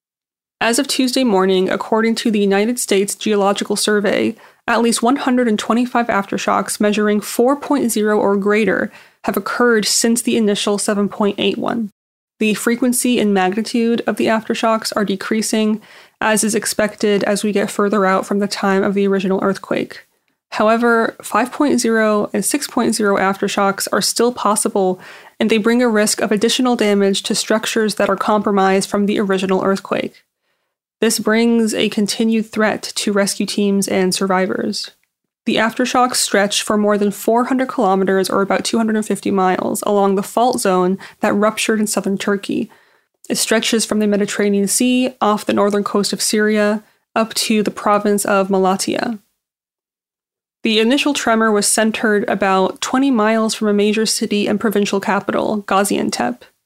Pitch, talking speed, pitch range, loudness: 210 Hz, 145 wpm, 200-230 Hz, -16 LUFS